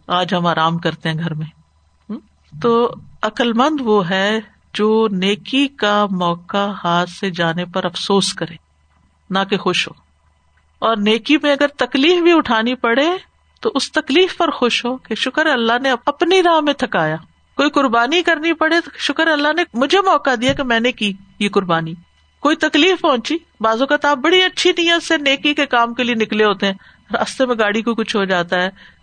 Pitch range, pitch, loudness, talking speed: 190-290 Hz, 230 Hz, -16 LUFS, 185 wpm